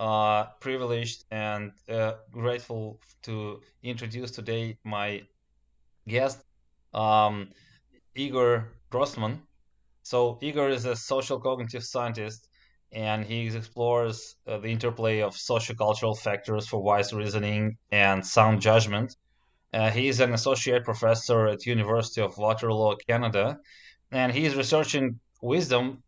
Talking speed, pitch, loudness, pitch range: 115 wpm, 115 Hz, -27 LUFS, 105-125 Hz